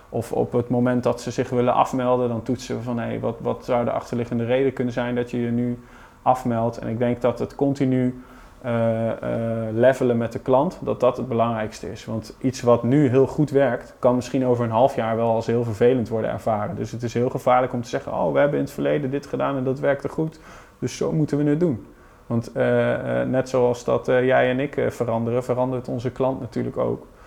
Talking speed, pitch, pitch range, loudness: 235 wpm, 125 Hz, 115-130 Hz, -22 LUFS